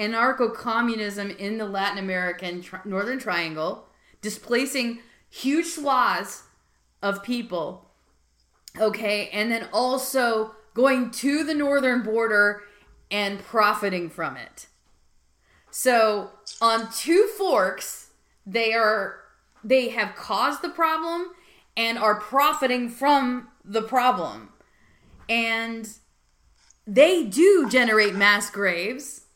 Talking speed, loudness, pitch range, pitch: 105 wpm, -23 LUFS, 205-260 Hz, 225 Hz